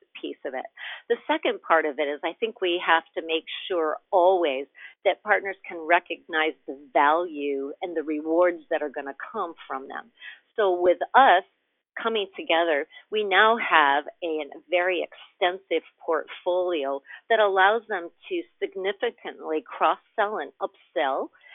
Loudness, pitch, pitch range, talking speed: -25 LUFS, 180 Hz, 160-215 Hz, 155 wpm